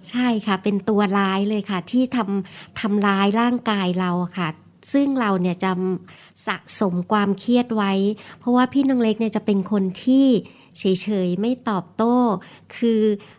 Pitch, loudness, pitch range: 205 Hz, -21 LUFS, 190-235 Hz